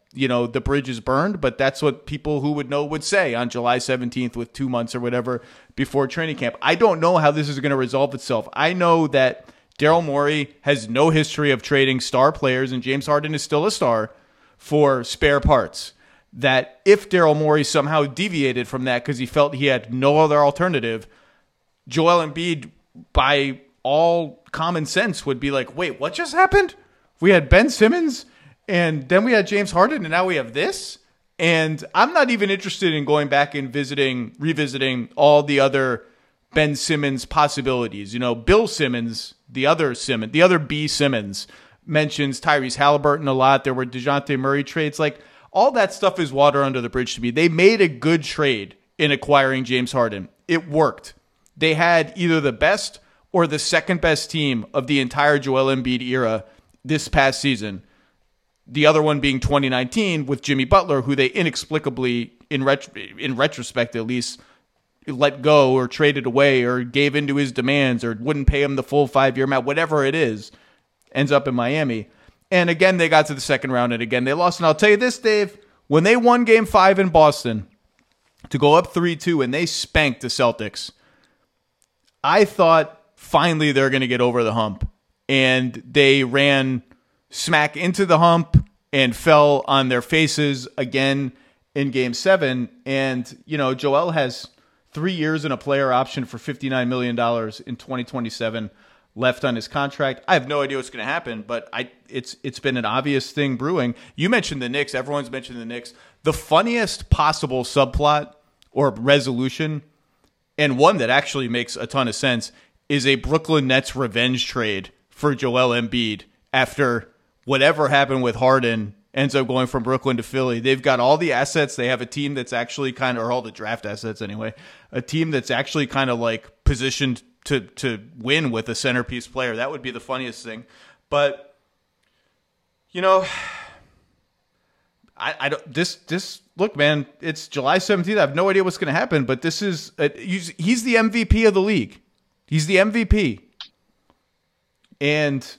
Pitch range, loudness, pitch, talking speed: 125-155 Hz, -20 LUFS, 140 Hz, 180 wpm